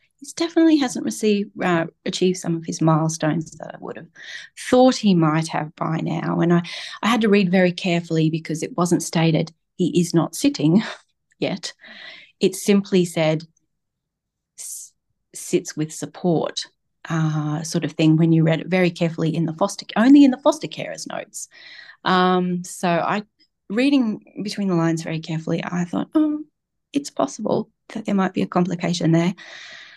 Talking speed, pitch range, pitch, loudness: 165 wpm, 160-205 Hz, 175 Hz, -21 LUFS